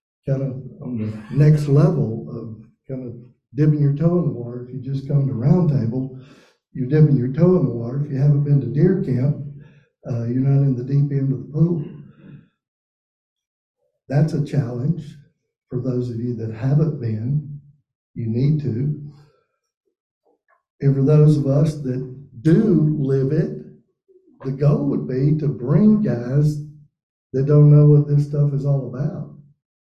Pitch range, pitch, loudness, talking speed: 130-150 Hz, 145 Hz, -19 LUFS, 170 wpm